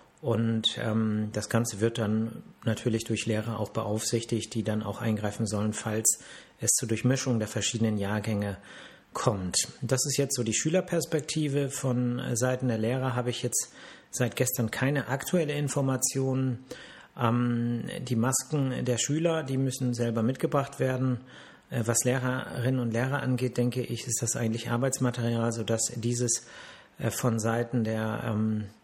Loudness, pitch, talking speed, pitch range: -29 LUFS, 120 Hz, 150 wpm, 110-130 Hz